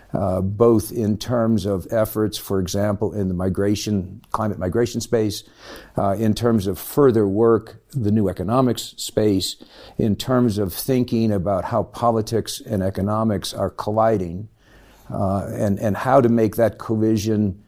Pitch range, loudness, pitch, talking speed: 100-115 Hz, -21 LUFS, 110 Hz, 145 wpm